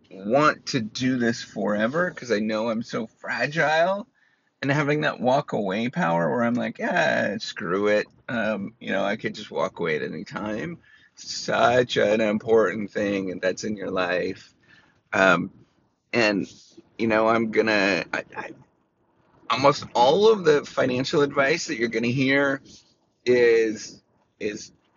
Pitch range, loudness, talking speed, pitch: 105-140 Hz, -23 LUFS, 150 wpm, 115 Hz